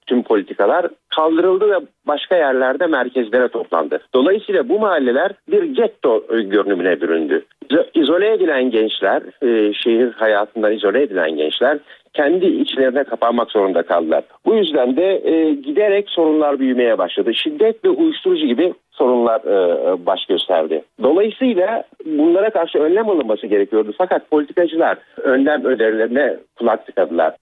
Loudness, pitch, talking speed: -16 LUFS, 185 Hz, 125 wpm